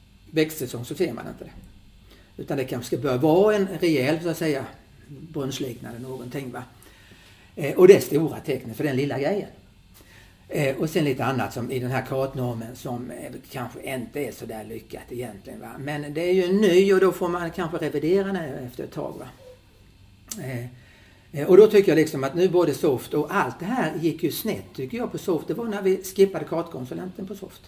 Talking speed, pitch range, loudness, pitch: 190 wpm, 115-170 Hz, -23 LUFS, 135 Hz